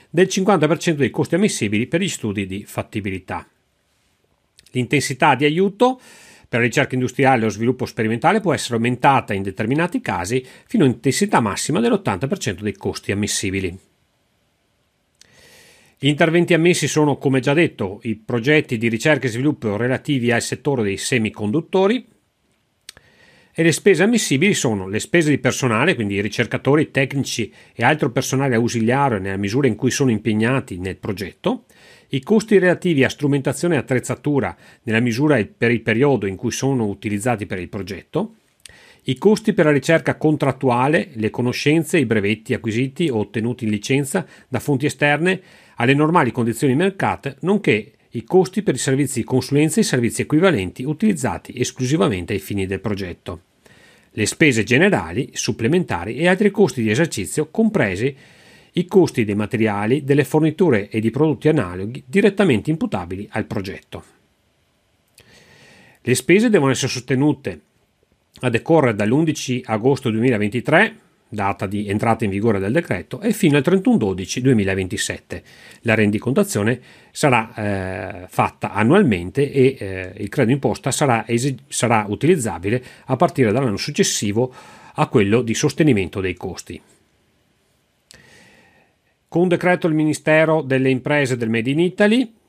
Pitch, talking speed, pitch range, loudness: 130 Hz, 145 wpm, 110-155 Hz, -19 LUFS